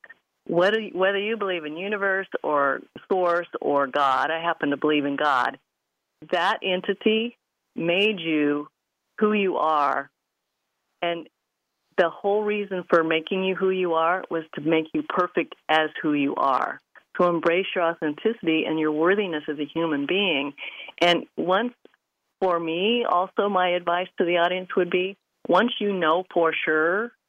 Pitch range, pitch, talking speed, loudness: 155-195 Hz, 175 Hz, 155 wpm, -24 LUFS